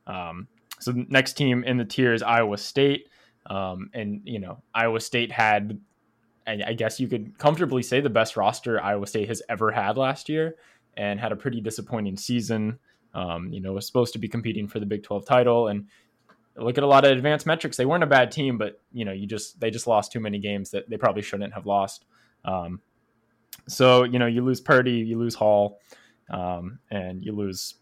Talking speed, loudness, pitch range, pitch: 210 wpm, -24 LUFS, 100-125 Hz, 115 Hz